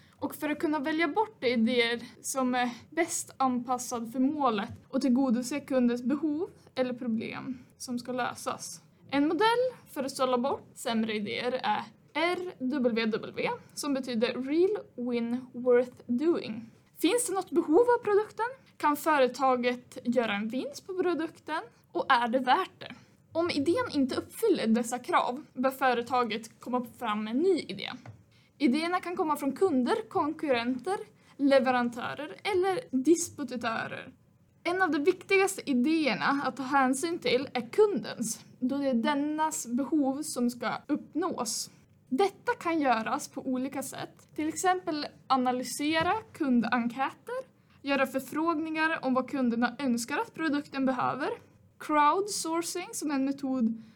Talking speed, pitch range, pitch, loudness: 135 wpm, 245-330 Hz, 270 Hz, -29 LUFS